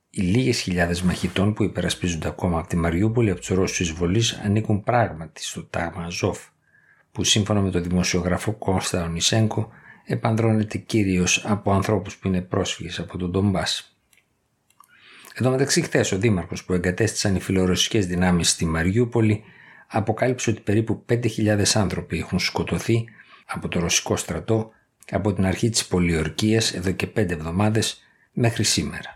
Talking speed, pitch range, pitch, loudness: 145 wpm, 90-110 Hz, 100 Hz, -22 LUFS